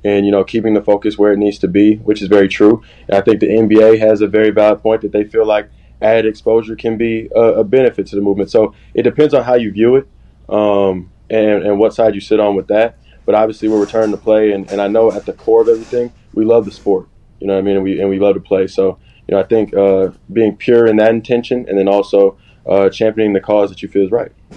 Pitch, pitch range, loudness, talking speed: 105 Hz, 100-110 Hz, -13 LUFS, 270 wpm